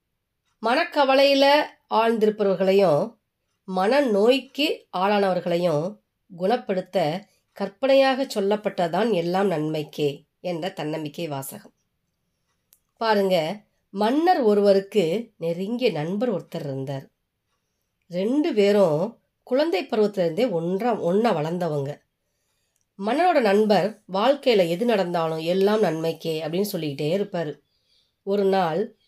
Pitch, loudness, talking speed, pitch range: 195 Hz, -23 LUFS, 80 wpm, 170-230 Hz